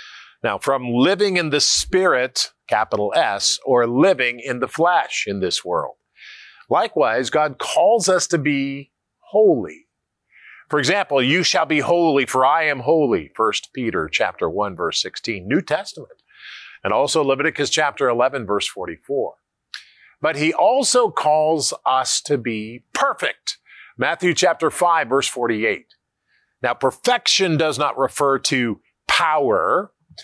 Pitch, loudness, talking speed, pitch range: 155 Hz, -19 LUFS, 135 wpm, 135-190 Hz